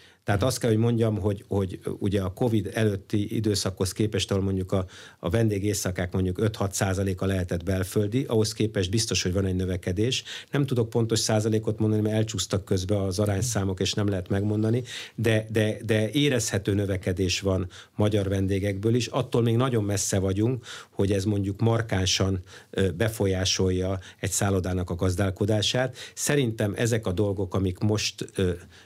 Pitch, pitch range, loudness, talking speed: 100 Hz, 95-110 Hz, -26 LUFS, 150 wpm